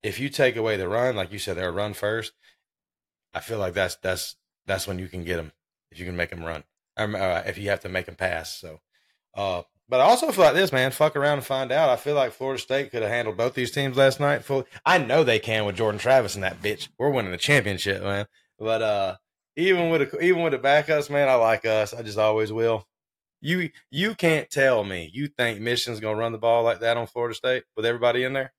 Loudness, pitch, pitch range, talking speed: -24 LUFS, 115 Hz, 105-135 Hz, 250 wpm